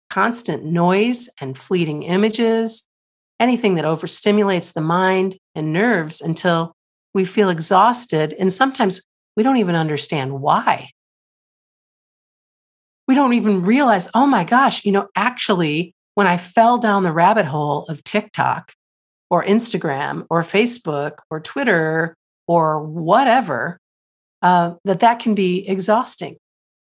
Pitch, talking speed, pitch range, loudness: 190 Hz, 125 wpm, 165-220 Hz, -18 LUFS